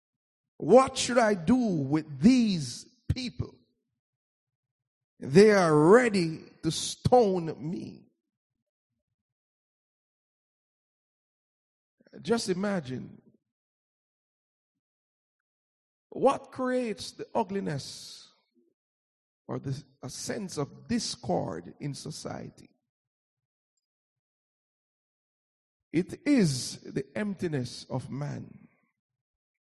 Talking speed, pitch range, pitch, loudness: 65 wpm, 130-210 Hz, 155 Hz, -27 LUFS